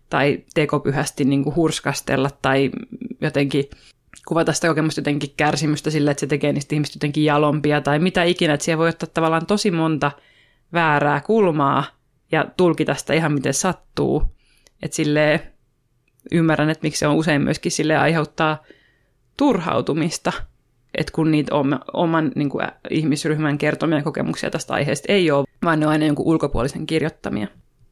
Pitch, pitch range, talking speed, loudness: 150 Hz, 145-160 Hz, 145 wpm, -20 LUFS